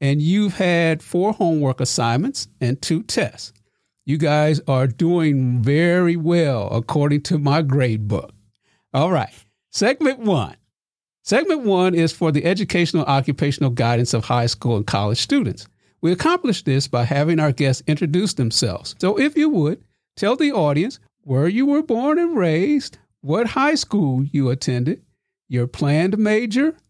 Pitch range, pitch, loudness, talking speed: 125-180 Hz, 150 Hz, -19 LUFS, 150 wpm